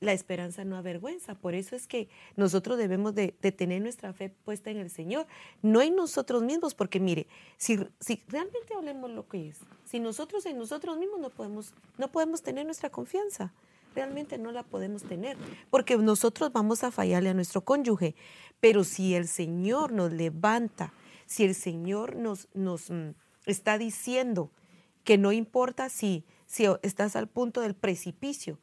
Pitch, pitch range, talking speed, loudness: 210 Hz, 185-250 Hz, 170 wpm, -30 LUFS